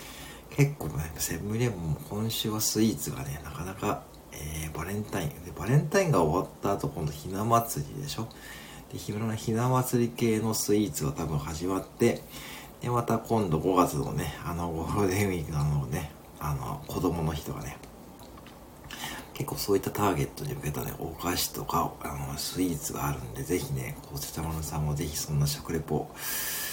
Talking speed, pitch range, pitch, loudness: 345 characters per minute, 75-115 Hz, 95 Hz, -30 LUFS